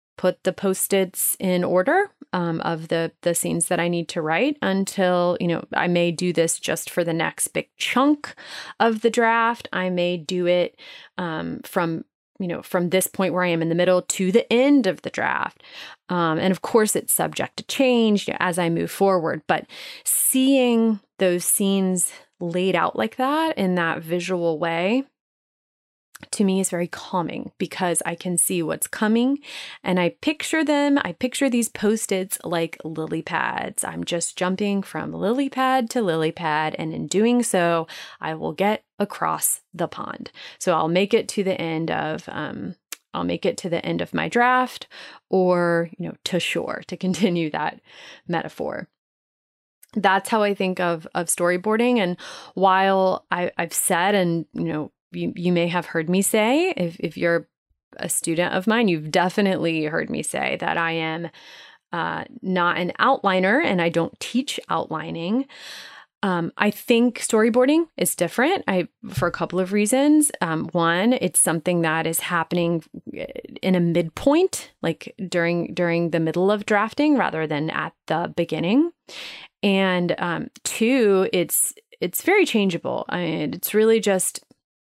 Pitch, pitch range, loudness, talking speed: 185 Hz, 170-230 Hz, -22 LUFS, 170 wpm